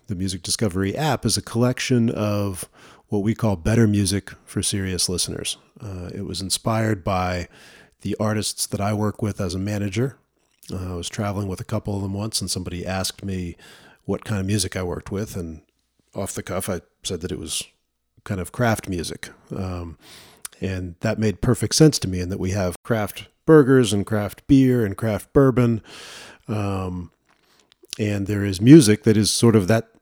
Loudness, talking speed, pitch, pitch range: -22 LUFS, 190 wpm, 100 Hz, 95-110 Hz